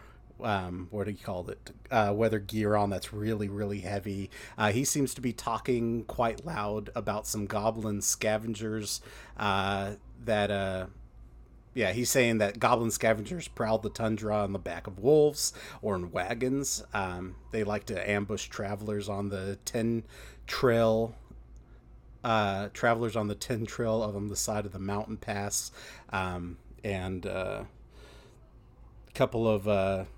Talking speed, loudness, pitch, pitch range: 150 wpm, -31 LUFS, 105 Hz, 100-115 Hz